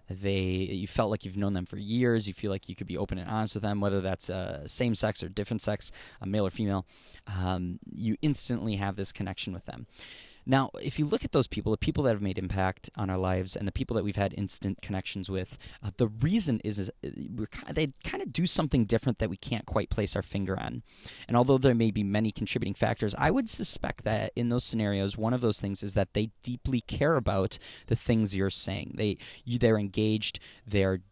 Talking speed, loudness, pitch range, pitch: 230 wpm, -30 LUFS, 95-115 Hz, 105 Hz